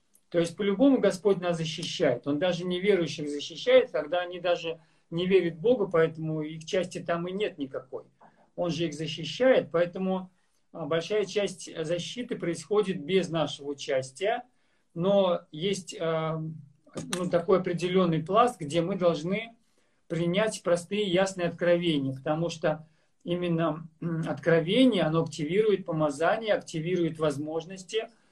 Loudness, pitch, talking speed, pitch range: -28 LUFS, 175 Hz, 125 wpm, 160-195 Hz